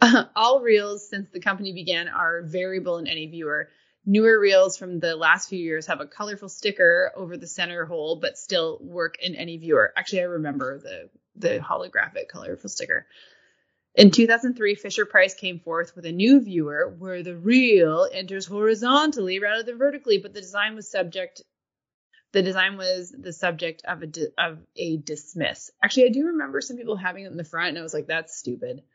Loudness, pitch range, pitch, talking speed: -23 LUFS, 170-225 Hz, 190 Hz, 190 wpm